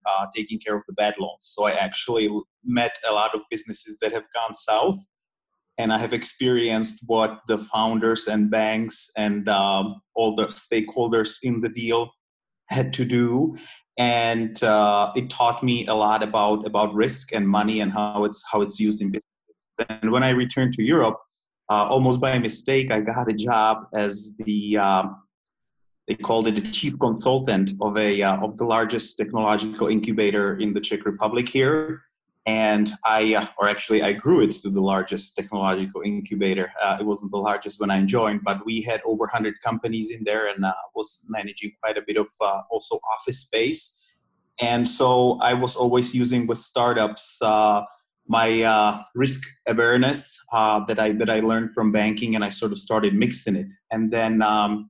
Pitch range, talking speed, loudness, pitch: 105-120 Hz, 185 wpm, -22 LUFS, 110 Hz